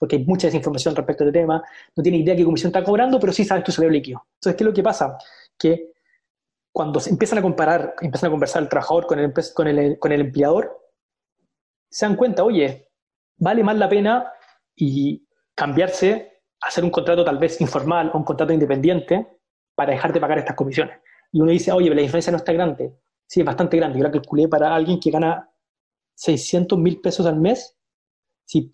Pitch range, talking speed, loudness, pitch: 155-190 Hz, 205 wpm, -20 LUFS, 170 Hz